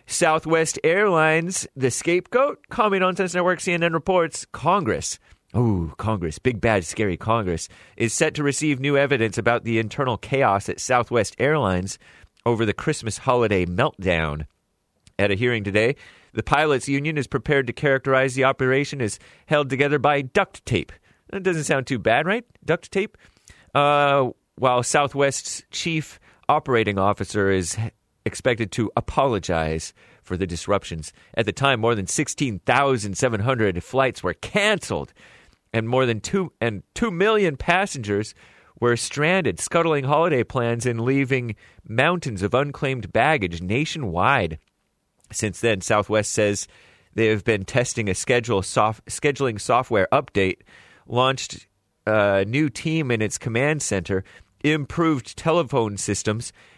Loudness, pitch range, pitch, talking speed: -22 LUFS, 105-145 Hz, 120 Hz, 135 wpm